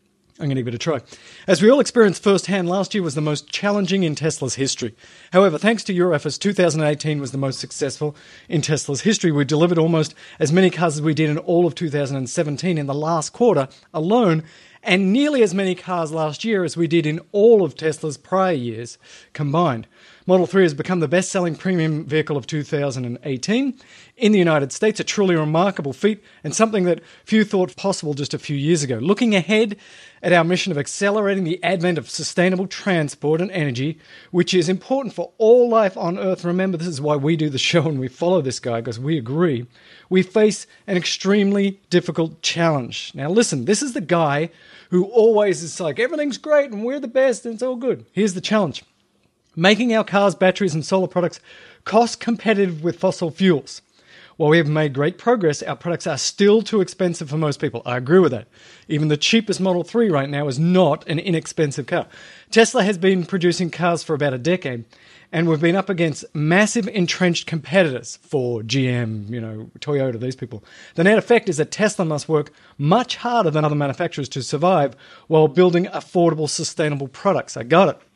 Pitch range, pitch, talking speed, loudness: 150-195 Hz, 170 Hz, 195 wpm, -19 LUFS